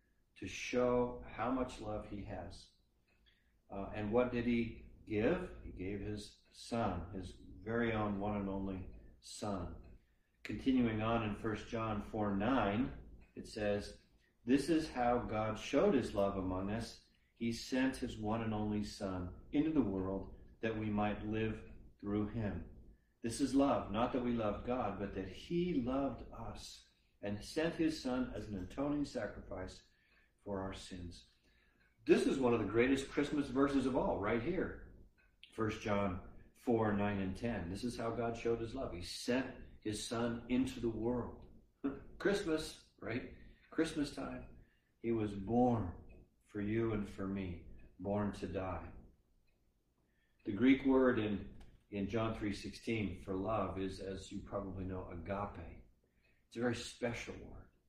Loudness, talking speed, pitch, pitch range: -38 LUFS, 155 wpm, 105 Hz, 95-120 Hz